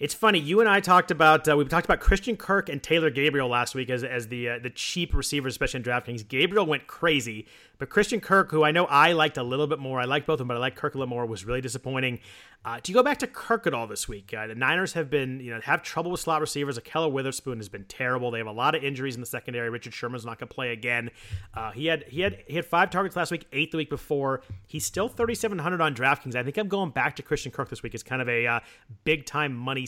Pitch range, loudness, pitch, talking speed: 125-165 Hz, -26 LUFS, 140 Hz, 280 wpm